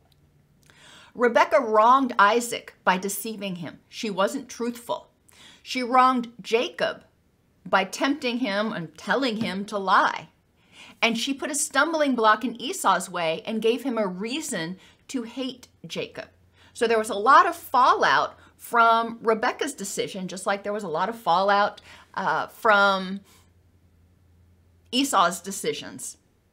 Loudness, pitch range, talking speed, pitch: -23 LUFS, 190-255 Hz, 135 wpm, 220 Hz